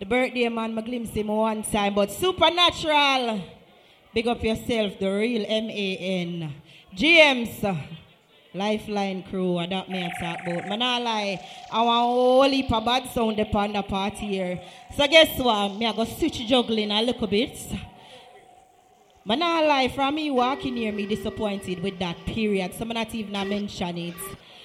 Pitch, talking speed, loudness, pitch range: 220 Hz, 180 wpm, -23 LUFS, 195-245 Hz